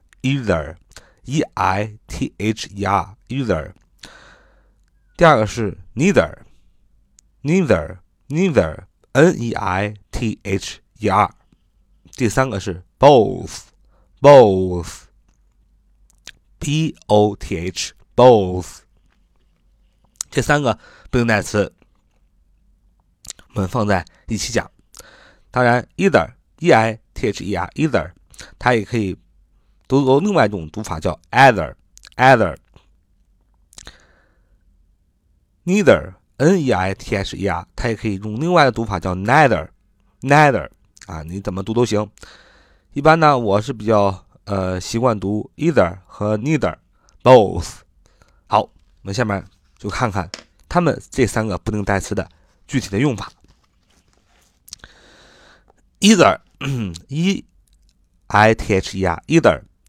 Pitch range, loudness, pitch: 90-125 Hz, -18 LUFS, 100 Hz